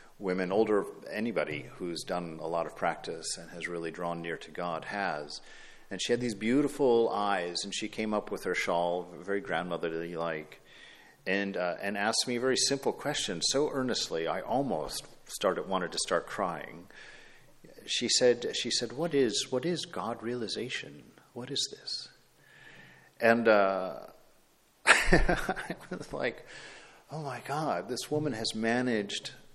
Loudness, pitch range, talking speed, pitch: -31 LUFS, 90-125 Hz, 155 wpm, 110 Hz